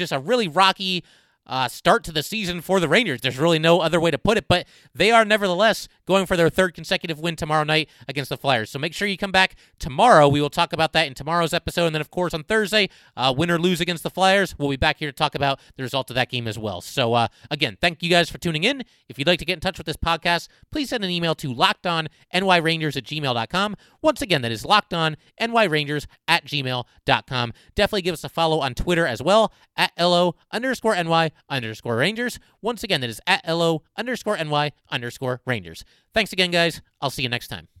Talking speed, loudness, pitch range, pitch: 230 wpm, -21 LUFS, 140-185 Hz, 165 Hz